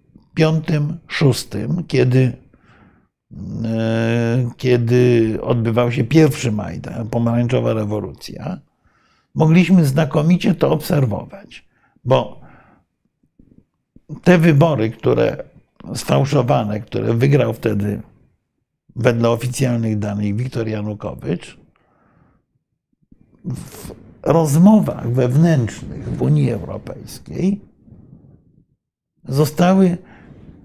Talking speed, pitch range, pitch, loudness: 70 wpm, 115-155 Hz, 125 Hz, -17 LUFS